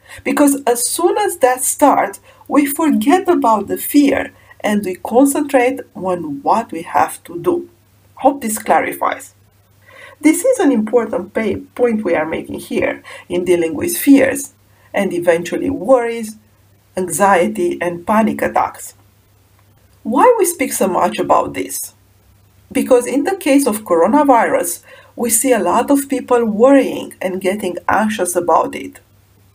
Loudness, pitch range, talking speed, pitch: -15 LUFS, 175-275 Hz, 140 wpm, 230 Hz